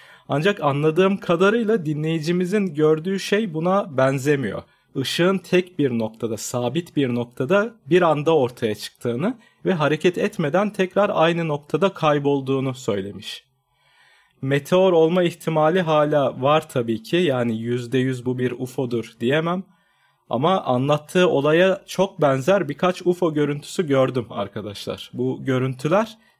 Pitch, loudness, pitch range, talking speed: 155 Hz, -21 LUFS, 130-180 Hz, 120 wpm